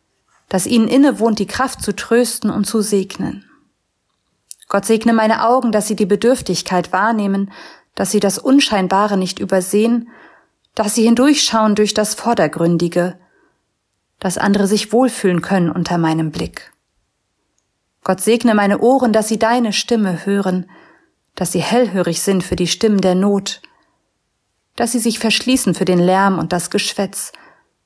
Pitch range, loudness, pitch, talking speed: 185-230 Hz, -15 LUFS, 205 Hz, 145 wpm